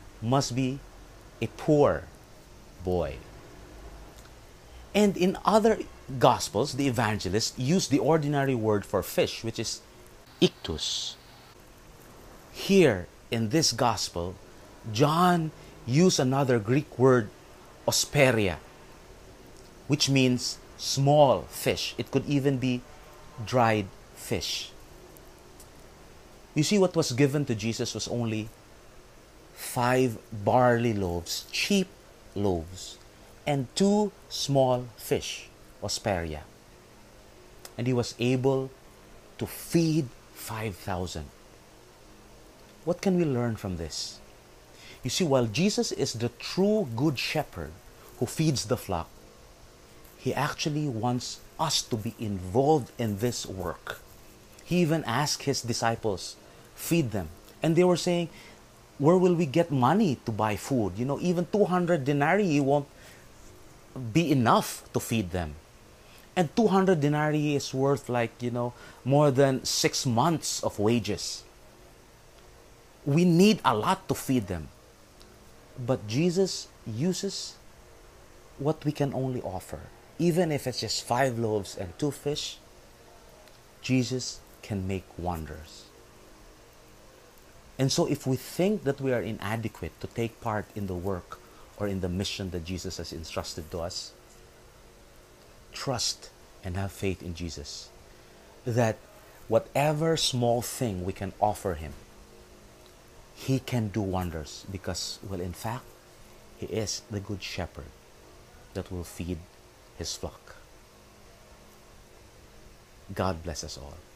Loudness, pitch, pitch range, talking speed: -28 LUFS, 120 Hz, 100-145 Hz, 120 wpm